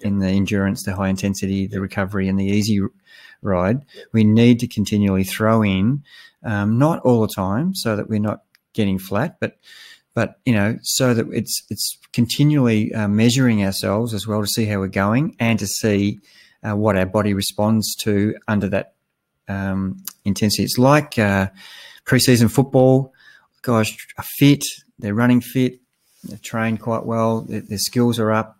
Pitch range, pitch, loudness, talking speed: 100-120 Hz, 110 Hz, -19 LUFS, 165 wpm